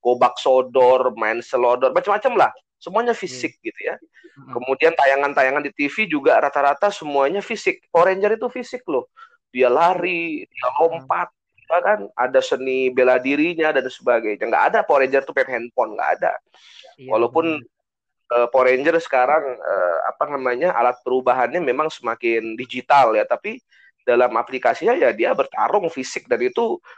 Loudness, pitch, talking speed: -19 LUFS, 145 Hz, 140 wpm